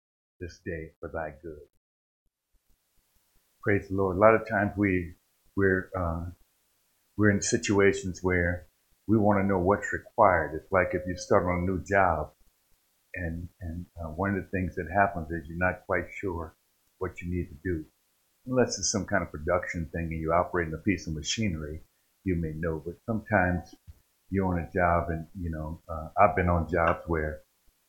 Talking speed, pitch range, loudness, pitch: 185 wpm, 80-95 Hz, -28 LUFS, 90 Hz